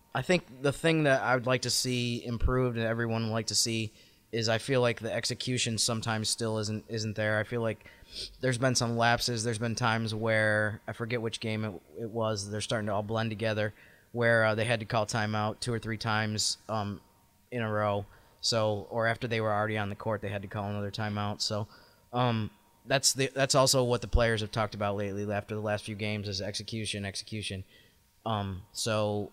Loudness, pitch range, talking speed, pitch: -30 LUFS, 105-120 Hz, 215 wpm, 110 Hz